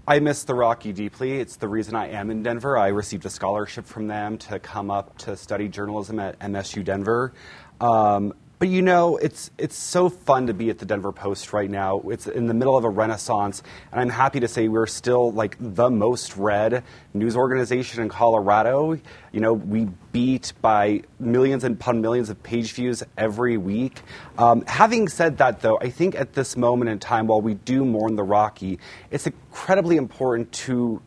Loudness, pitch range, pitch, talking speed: -22 LUFS, 105-130 Hz, 115 Hz, 195 wpm